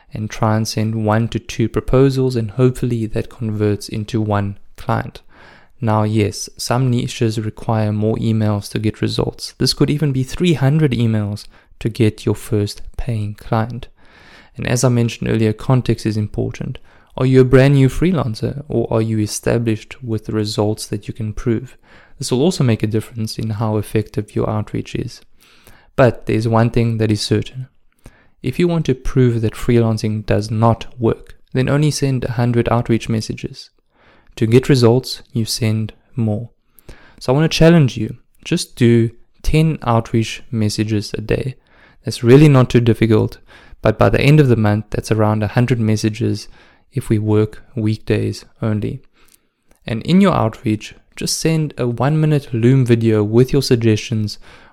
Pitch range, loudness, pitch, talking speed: 110-130 Hz, -17 LUFS, 115 Hz, 165 wpm